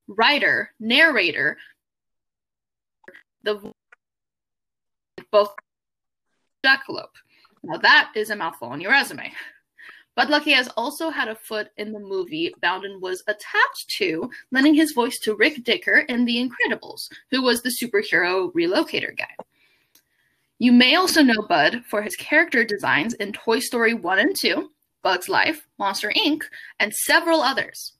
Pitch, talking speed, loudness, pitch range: 255 Hz, 135 wpm, -20 LUFS, 215-320 Hz